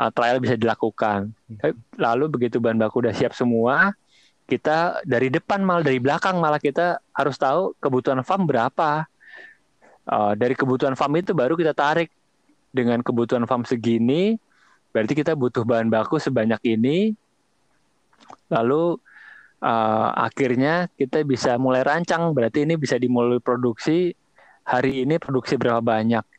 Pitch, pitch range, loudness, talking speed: 130 Hz, 115-155 Hz, -21 LUFS, 130 wpm